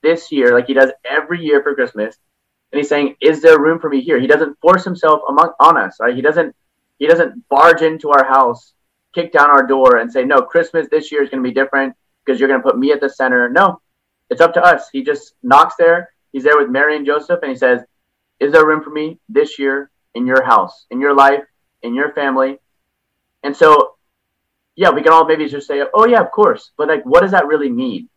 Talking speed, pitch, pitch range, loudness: 240 wpm, 150 Hz, 135-165 Hz, -13 LUFS